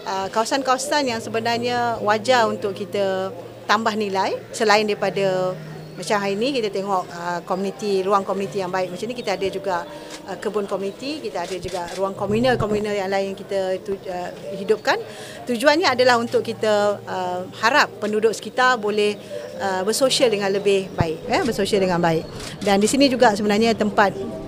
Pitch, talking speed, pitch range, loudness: 205 Hz, 160 wpm, 190-225 Hz, -21 LUFS